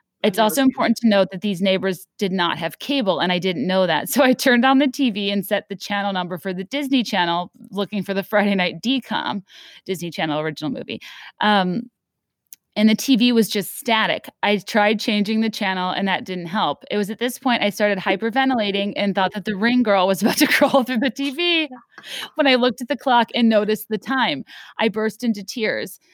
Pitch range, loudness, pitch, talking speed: 195-245 Hz, -20 LUFS, 210 Hz, 215 wpm